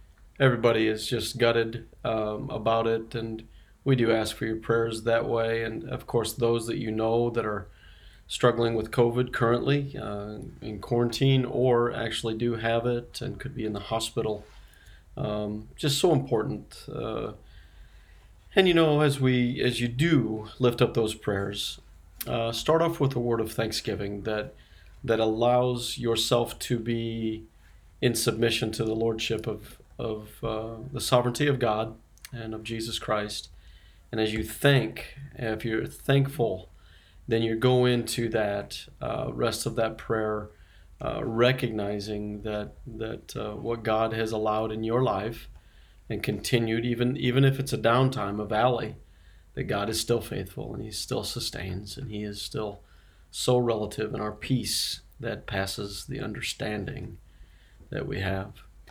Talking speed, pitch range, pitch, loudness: 155 wpm, 105-120 Hz, 115 Hz, -28 LUFS